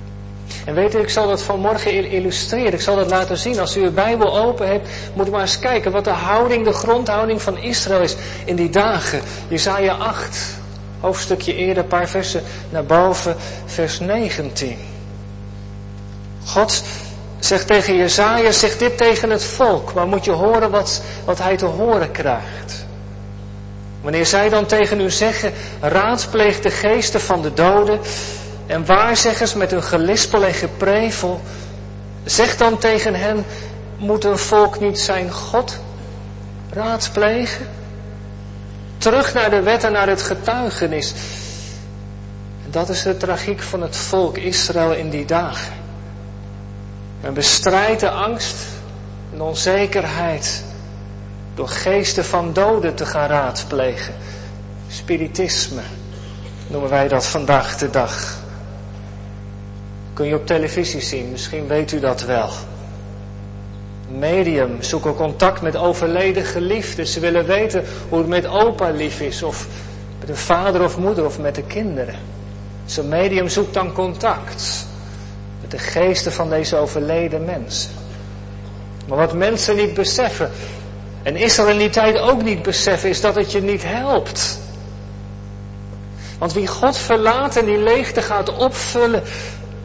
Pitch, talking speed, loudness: 155 Hz, 140 wpm, -17 LUFS